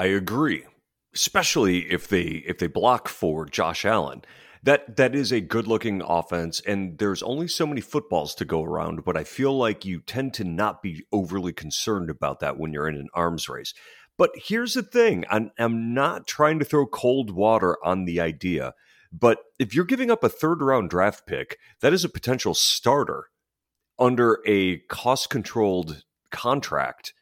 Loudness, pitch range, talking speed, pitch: -24 LUFS, 90-135 Hz, 180 wpm, 110 Hz